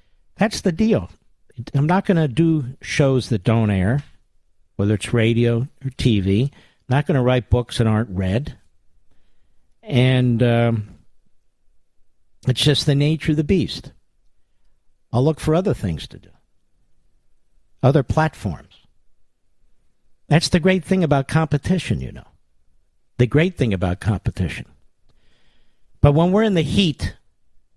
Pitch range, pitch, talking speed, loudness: 95-150 Hz, 120 Hz, 135 wpm, -19 LUFS